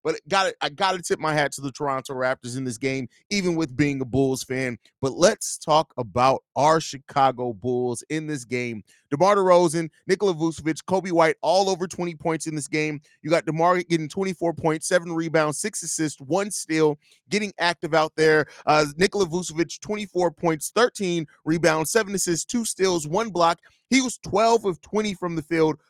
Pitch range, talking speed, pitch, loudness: 150-185 Hz, 190 wpm, 160 Hz, -23 LUFS